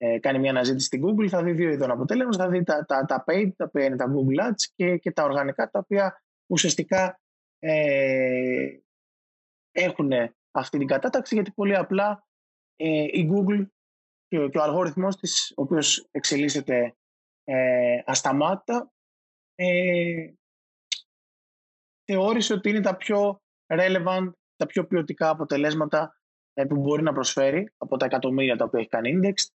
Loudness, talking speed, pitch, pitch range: -24 LUFS, 150 wpm, 170 Hz, 135-195 Hz